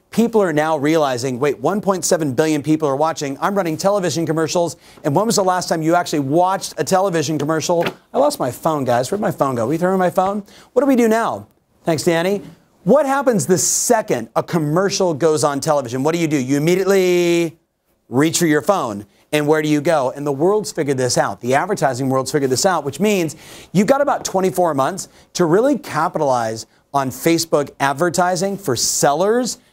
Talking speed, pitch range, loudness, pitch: 200 wpm, 150-190 Hz, -17 LUFS, 165 Hz